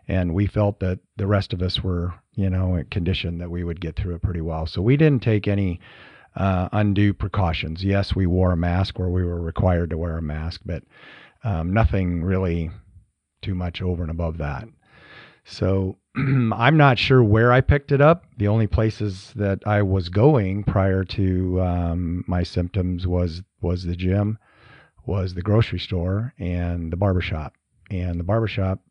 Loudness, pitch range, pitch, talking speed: -22 LUFS, 90-105 Hz, 95 Hz, 180 wpm